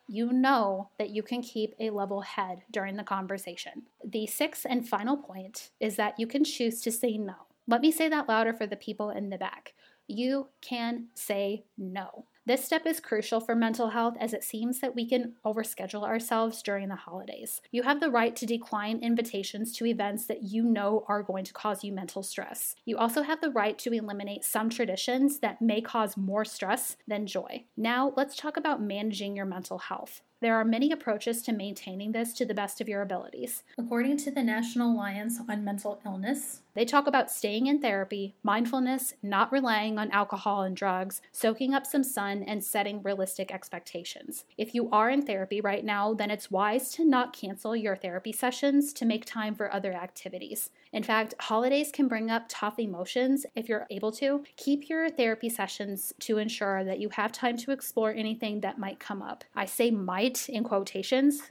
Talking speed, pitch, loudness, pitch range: 195 wpm, 220 Hz, -30 LUFS, 205-250 Hz